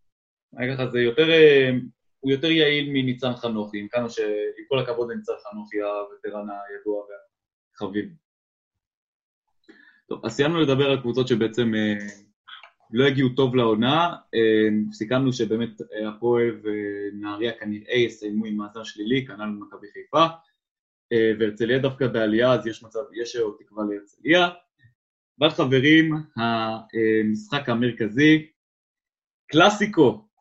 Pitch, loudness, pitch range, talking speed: 115 Hz, -22 LUFS, 105-135 Hz, 110 wpm